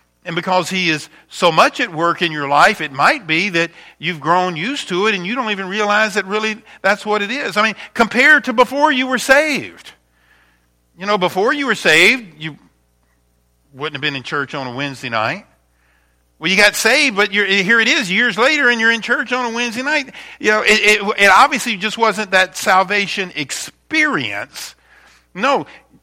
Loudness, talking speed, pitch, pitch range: -15 LUFS, 200 wpm, 200 Hz, 155-230 Hz